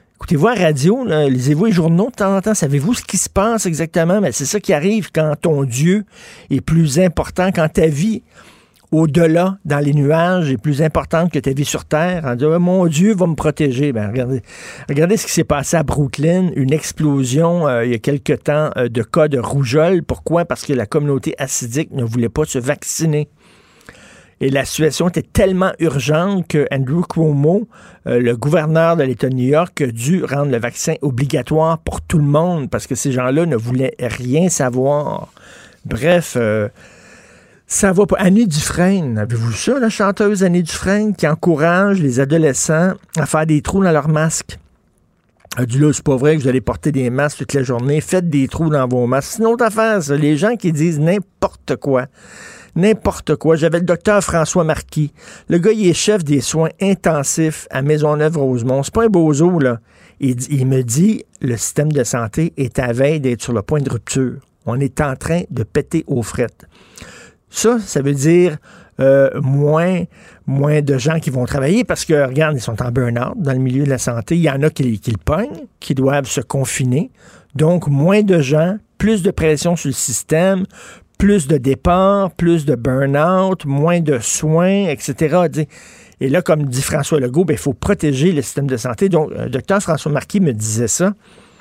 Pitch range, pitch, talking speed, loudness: 135-175 Hz, 155 Hz, 195 wpm, -16 LUFS